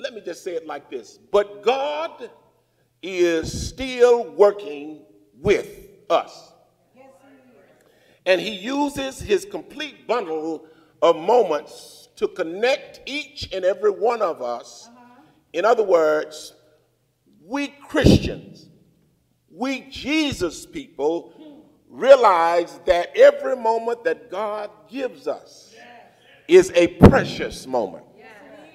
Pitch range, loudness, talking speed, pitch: 185-285 Hz, -20 LUFS, 105 wpm, 245 Hz